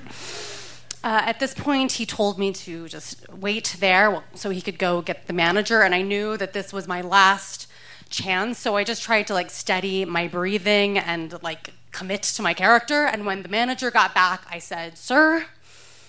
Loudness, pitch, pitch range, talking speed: -22 LUFS, 195 Hz, 180-215 Hz, 195 wpm